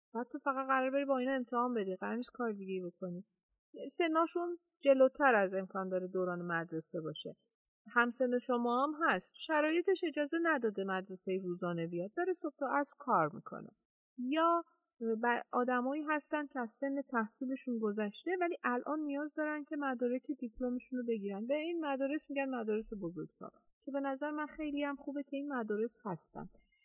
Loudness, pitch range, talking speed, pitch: -36 LUFS, 220-295 Hz, 160 wpm, 260 Hz